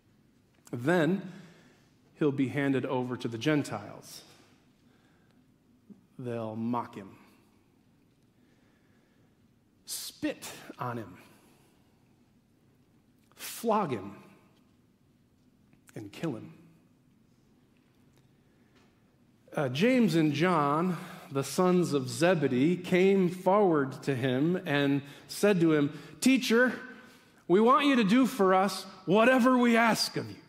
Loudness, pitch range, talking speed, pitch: -28 LUFS, 140-200 Hz, 95 wpm, 170 Hz